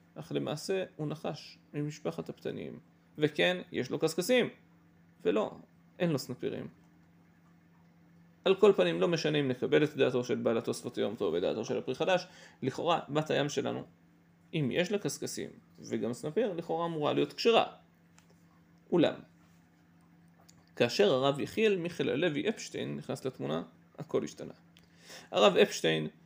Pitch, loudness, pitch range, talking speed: 165 Hz, -32 LUFS, 140-175 Hz, 135 wpm